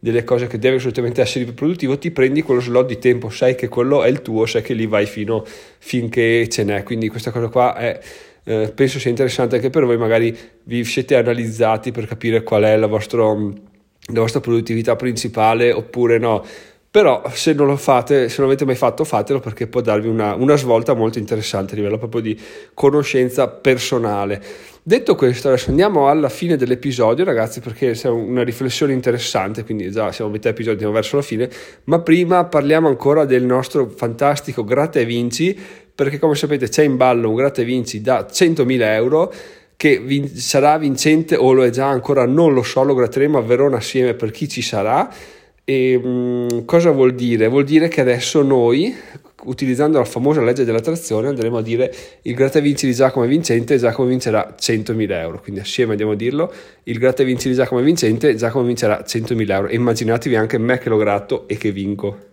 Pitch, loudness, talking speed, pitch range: 125 Hz, -17 LUFS, 195 wpm, 115-135 Hz